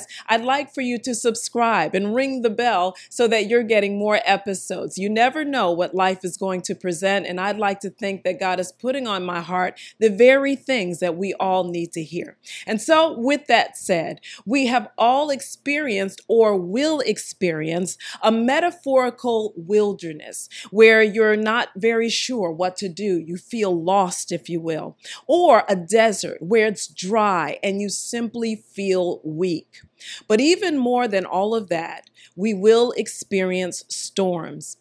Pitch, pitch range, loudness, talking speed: 205 Hz, 185-235 Hz, -21 LUFS, 165 wpm